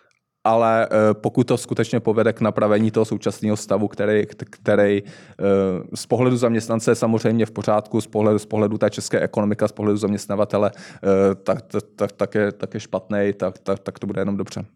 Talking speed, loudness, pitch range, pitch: 180 wpm, -21 LUFS, 100-110 Hz, 105 Hz